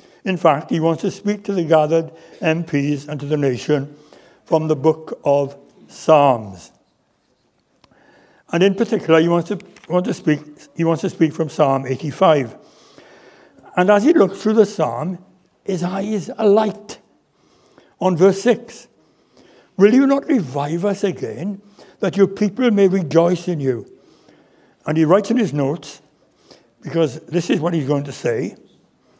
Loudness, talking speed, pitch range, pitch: -18 LUFS, 155 wpm, 150-200 Hz, 170 Hz